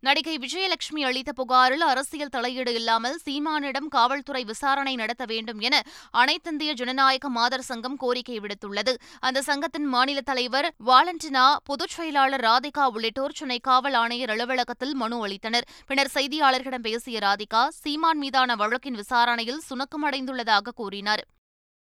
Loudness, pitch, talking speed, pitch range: -24 LUFS, 260 Hz, 120 wpm, 240-280 Hz